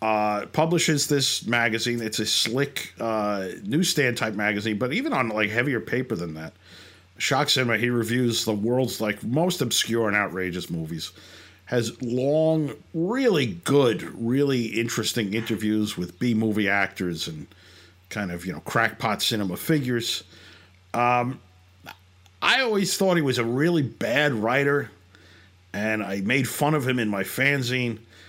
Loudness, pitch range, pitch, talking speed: -24 LUFS, 95-130 Hz, 115 Hz, 145 wpm